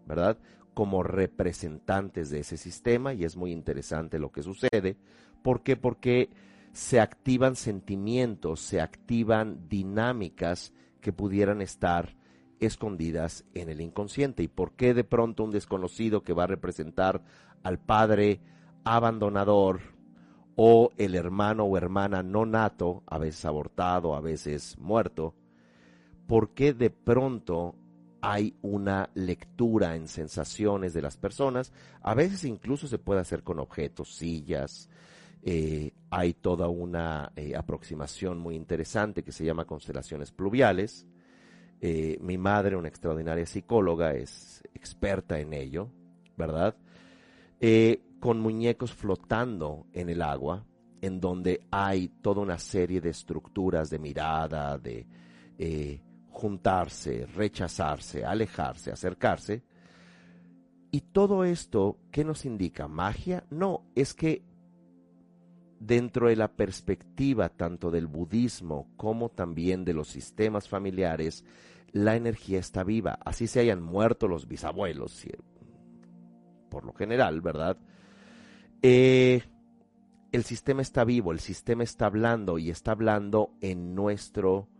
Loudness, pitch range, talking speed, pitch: -29 LUFS, 85-110 Hz, 125 wpm, 95 Hz